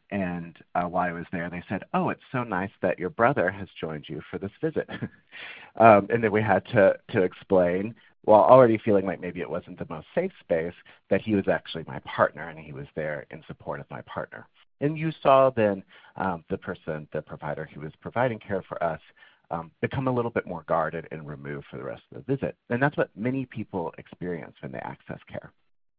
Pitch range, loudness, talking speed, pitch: 85-120 Hz, -26 LUFS, 220 wpm, 100 Hz